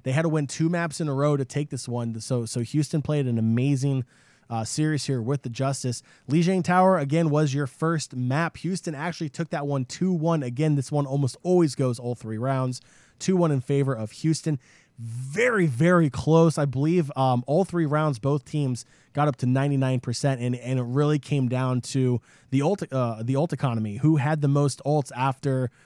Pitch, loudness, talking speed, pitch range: 140 Hz, -25 LUFS, 205 wpm, 130-155 Hz